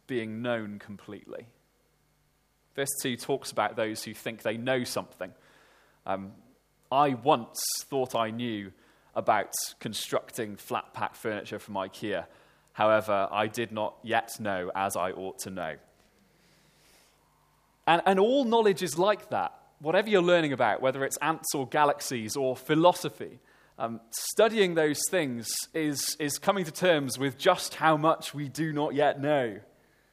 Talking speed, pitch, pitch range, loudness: 145 wpm, 135 Hz, 115-160 Hz, -28 LUFS